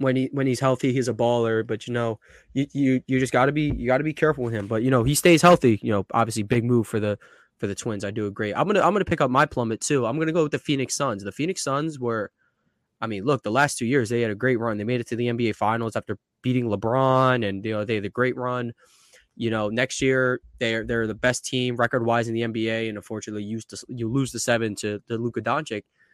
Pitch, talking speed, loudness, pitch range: 120 Hz, 275 wpm, -24 LUFS, 110-130 Hz